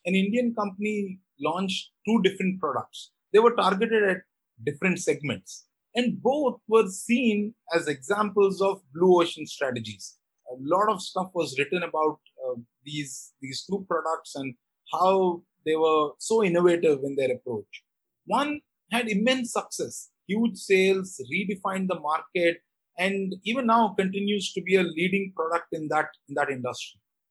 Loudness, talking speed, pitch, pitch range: -26 LUFS, 145 wpm, 190 Hz, 160-210 Hz